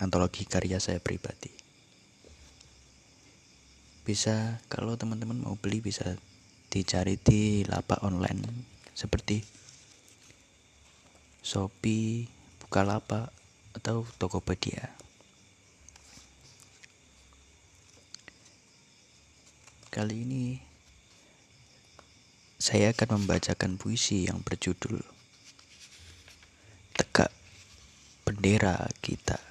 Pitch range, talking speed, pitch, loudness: 90-110 Hz, 60 wpm, 100 Hz, -31 LUFS